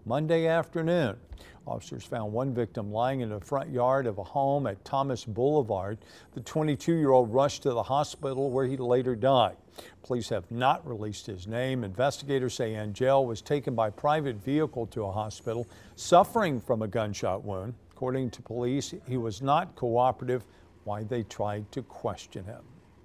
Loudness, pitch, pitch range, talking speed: -29 LUFS, 125 Hz, 110-135 Hz, 165 wpm